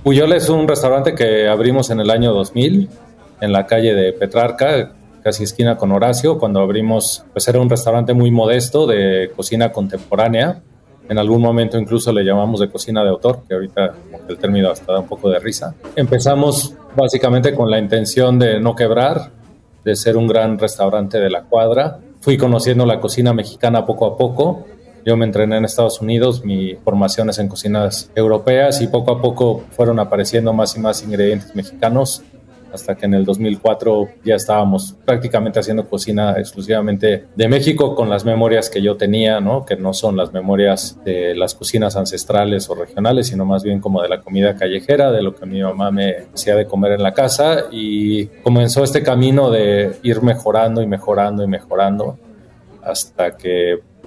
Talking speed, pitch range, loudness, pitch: 180 wpm, 100-120 Hz, -15 LUFS, 110 Hz